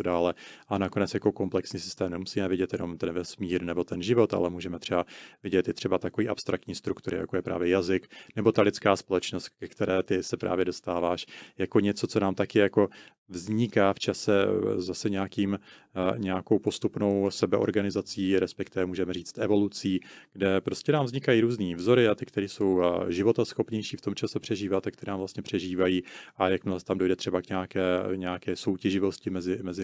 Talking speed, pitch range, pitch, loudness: 175 wpm, 90-105 Hz, 95 Hz, -28 LUFS